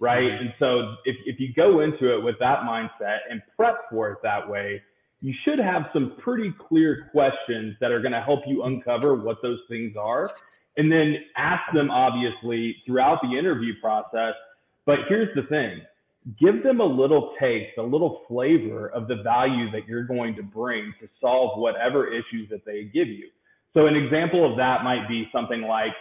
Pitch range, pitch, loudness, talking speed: 115-150 Hz, 125 Hz, -24 LUFS, 190 wpm